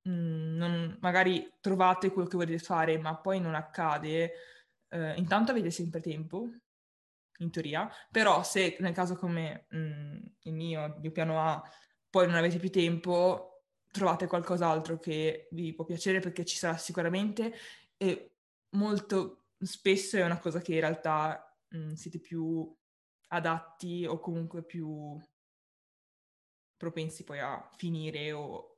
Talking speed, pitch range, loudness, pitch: 140 wpm, 160-185 Hz, -32 LUFS, 170 Hz